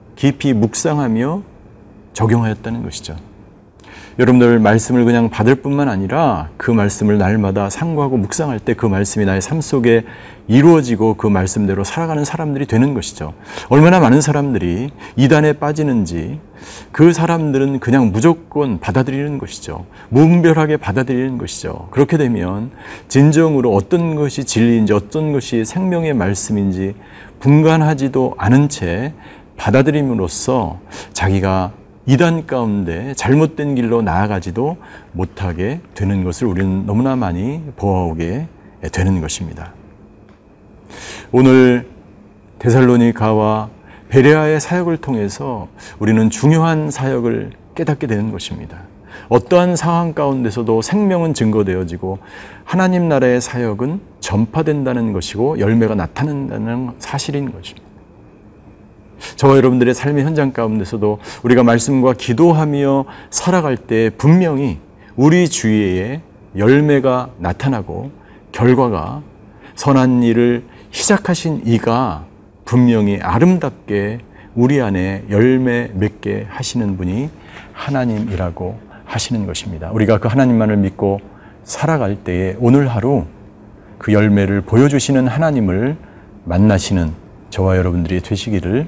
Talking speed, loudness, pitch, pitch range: 295 characters per minute, -15 LUFS, 115 Hz, 100-135 Hz